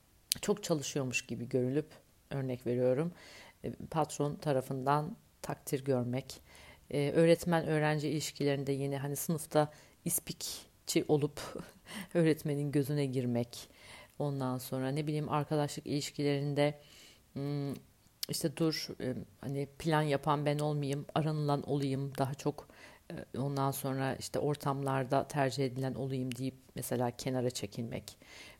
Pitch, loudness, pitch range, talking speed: 140 Hz, -35 LUFS, 130-150 Hz, 105 wpm